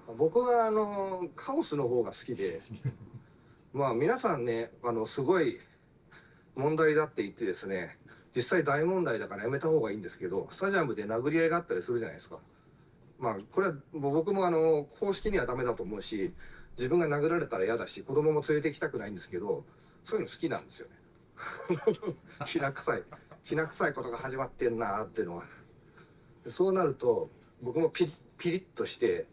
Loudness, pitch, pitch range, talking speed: -32 LUFS, 170 Hz, 145-245 Hz, 370 characters per minute